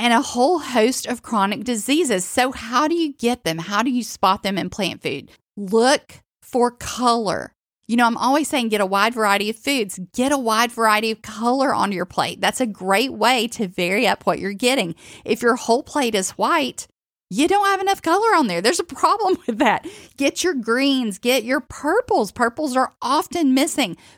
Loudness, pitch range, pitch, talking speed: -20 LUFS, 220-285 Hz, 245 Hz, 205 wpm